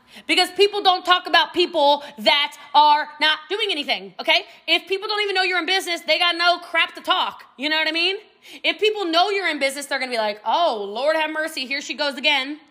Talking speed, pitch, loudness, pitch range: 230 wpm, 320 Hz, -19 LUFS, 295-360 Hz